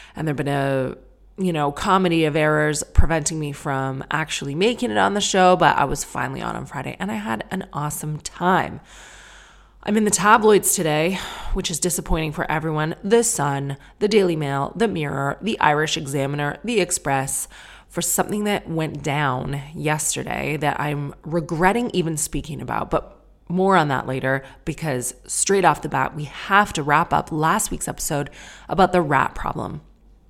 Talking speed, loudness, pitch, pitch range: 170 wpm, -21 LUFS, 160 Hz, 145-185 Hz